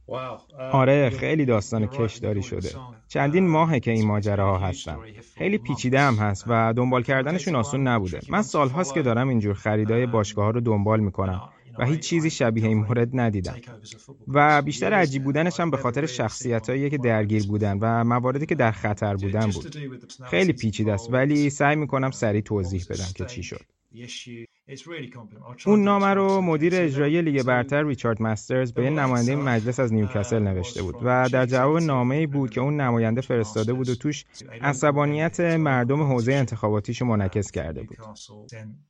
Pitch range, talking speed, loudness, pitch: 110-145 Hz, 165 wpm, -23 LUFS, 125 Hz